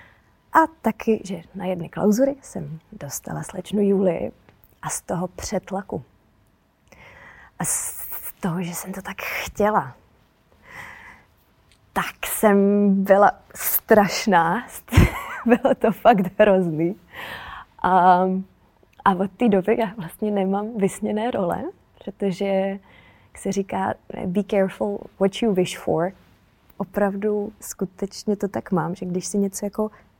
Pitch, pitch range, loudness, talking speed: 195 Hz, 185-210 Hz, -22 LUFS, 120 wpm